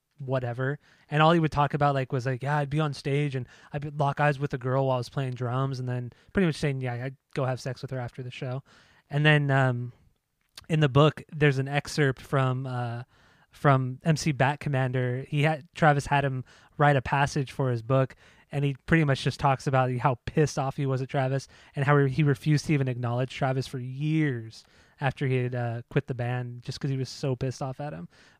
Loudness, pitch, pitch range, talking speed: -27 LUFS, 135 Hz, 130-145 Hz, 230 wpm